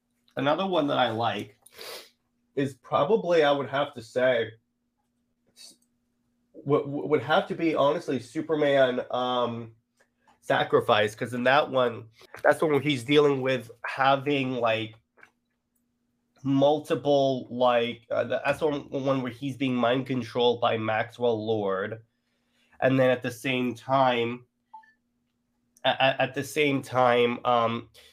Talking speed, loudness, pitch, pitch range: 125 wpm, -26 LUFS, 125 Hz, 120-140 Hz